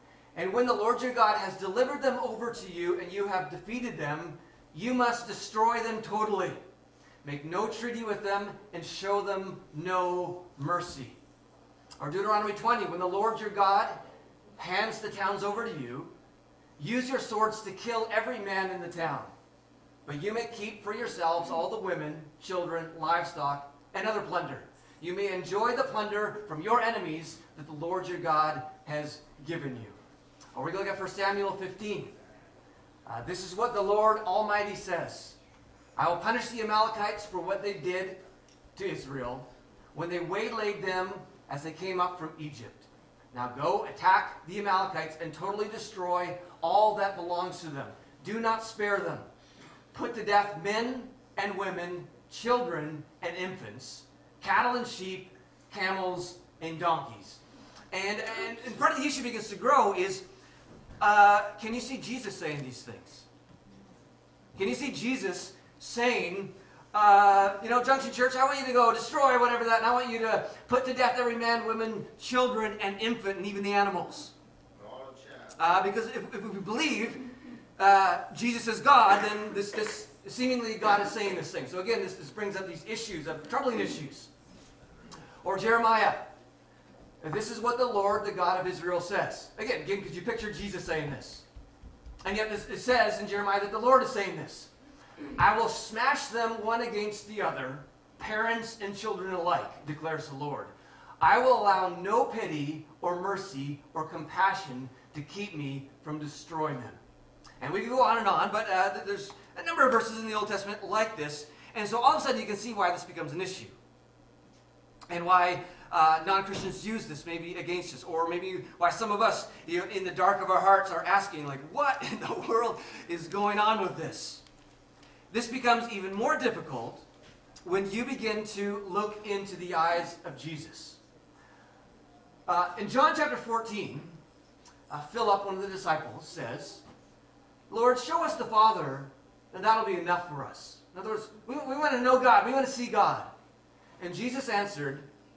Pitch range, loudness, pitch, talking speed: 170-225 Hz, -29 LUFS, 195 Hz, 175 wpm